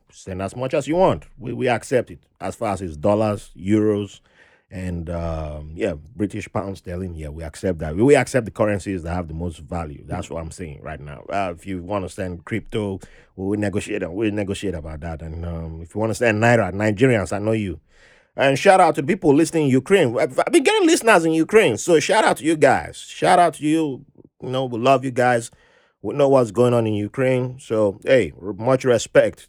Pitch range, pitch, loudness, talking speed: 90-130 Hz, 105 Hz, -20 LUFS, 225 wpm